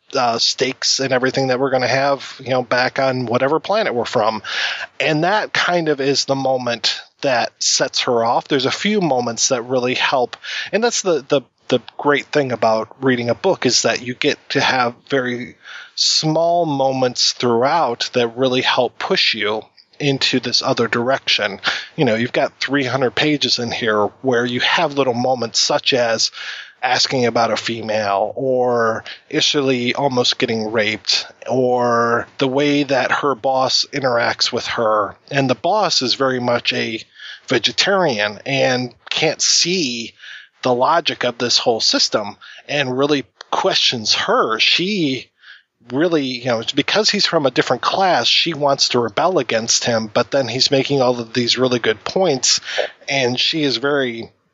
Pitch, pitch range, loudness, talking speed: 130 Hz, 120-140 Hz, -17 LUFS, 170 wpm